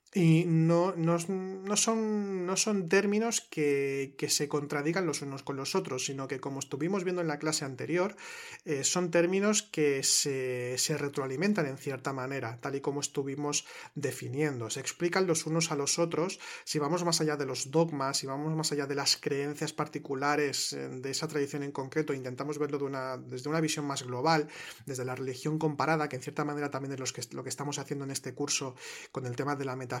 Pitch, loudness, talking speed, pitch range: 145 Hz, -31 LUFS, 205 wpm, 135-165 Hz